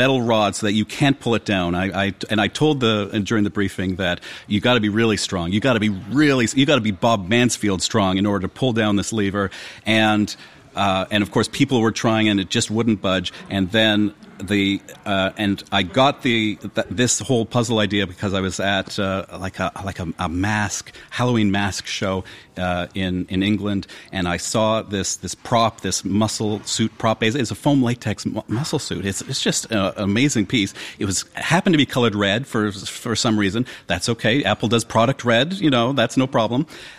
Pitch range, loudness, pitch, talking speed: 100-115 Hz, -20 LUFS, 105 Hz, 220 wpm